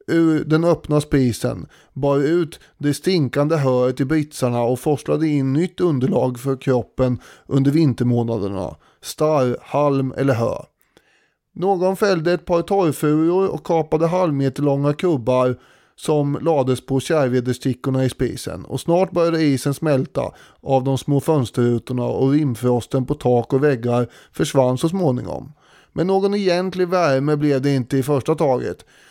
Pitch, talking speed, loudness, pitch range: 140 Hz, 140 wpm, -19 LUFS, 130-160 Hz